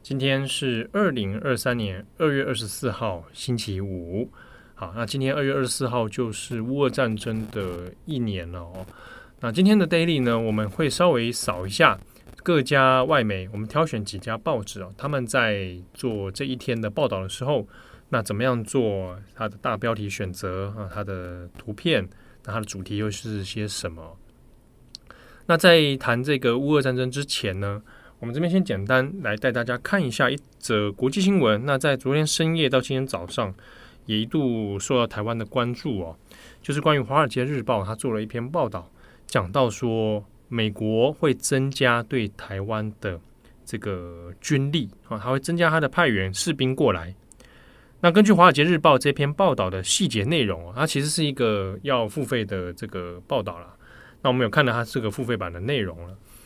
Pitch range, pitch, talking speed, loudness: 105-135 Hz, 120 Hz, 275 characters per minute, -24 LUFS